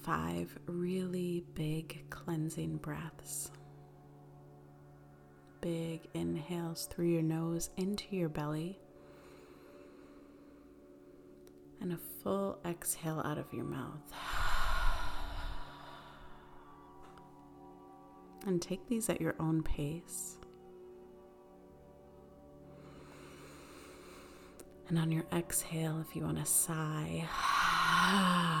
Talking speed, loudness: 80 wpm, -36 LUFS